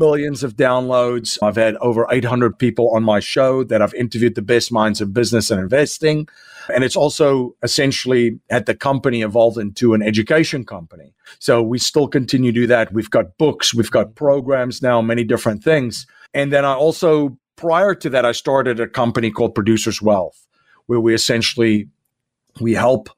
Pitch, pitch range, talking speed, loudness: 120 Hz, 115-135 Hz, 180 wpm, -17 LUFS